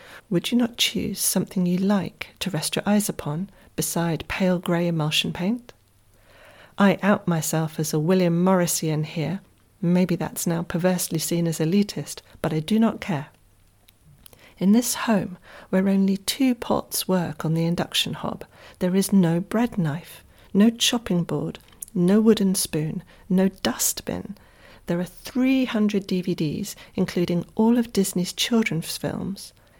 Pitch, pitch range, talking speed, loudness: 185 Hz, 165-205 Hz, 145 wpm, -23 LUFS